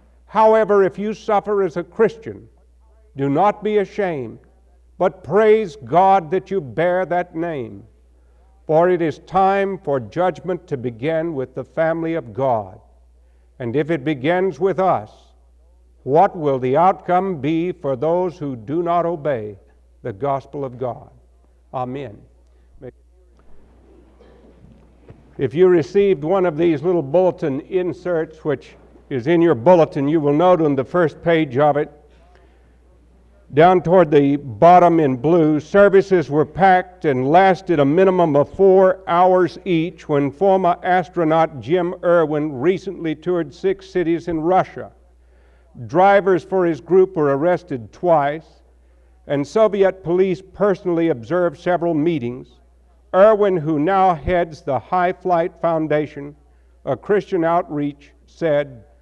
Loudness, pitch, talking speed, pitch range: -18 LUFS, 160 Hz, 135 wpm, 130-180 Hz